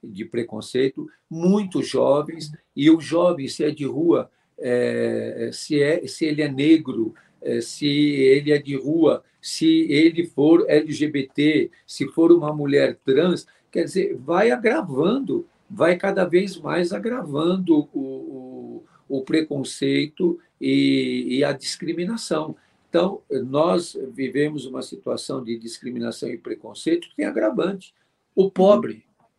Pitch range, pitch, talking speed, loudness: 135-175 Hz, 150 Hz, 130 wpm, -21 LUFS